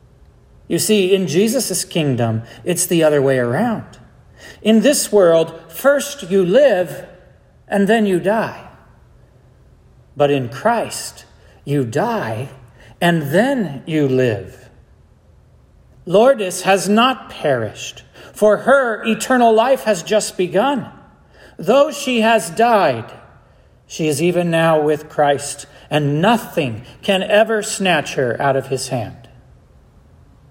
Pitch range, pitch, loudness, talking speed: 135-215 Hz, 175 Hz, -16 LUFS, 120 wpm